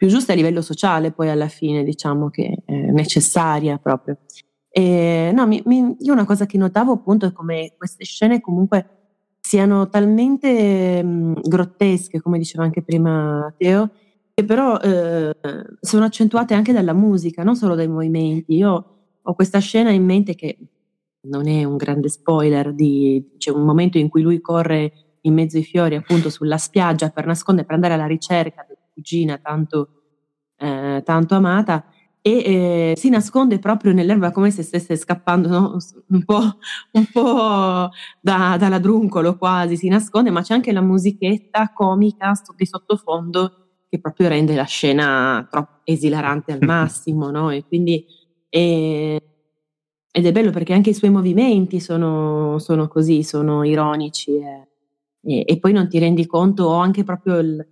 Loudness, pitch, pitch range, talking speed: -17 LUFS, 170 Hz, 155-195 Hz, 160 wpm